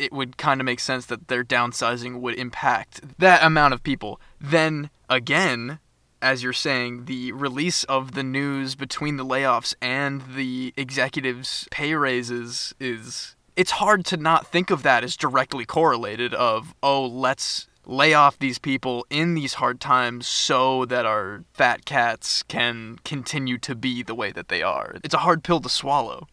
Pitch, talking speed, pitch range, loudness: 130 Hz, 170 wpm, 125-145 Hz, -22 LUFS